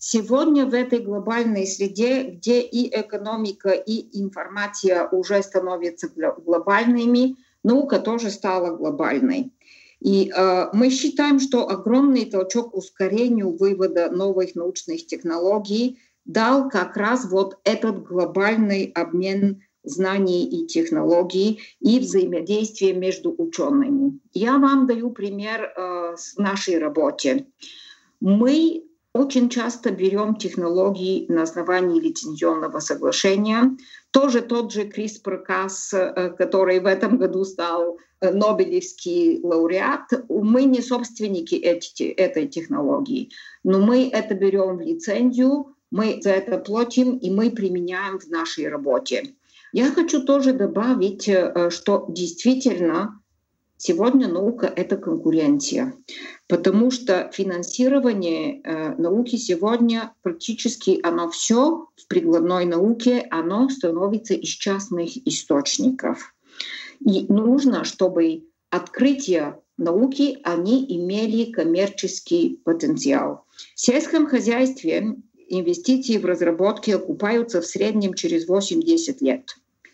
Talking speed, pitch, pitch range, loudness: 105 wpm, 210 Hz, 185-260 Hz, -21 LUFS